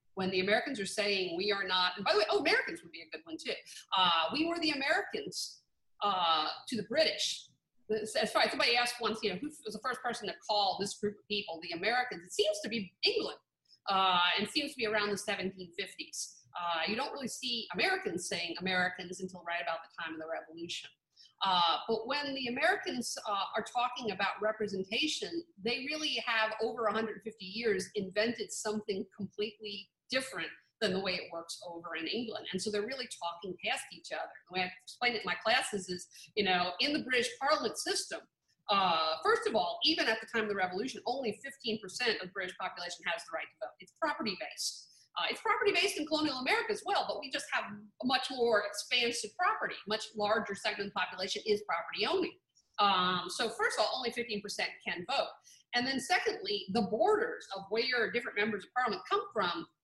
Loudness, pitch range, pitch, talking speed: -33 LUFS, 190-260 Hz, 215 Hz, 205 wpm